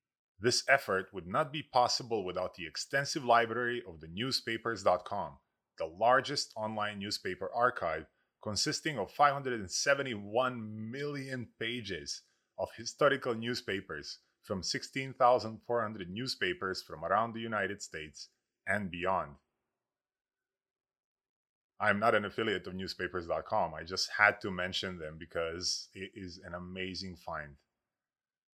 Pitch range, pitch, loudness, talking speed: 95-125 Hz, 115 Hz, -33 LUFS, 115 wpm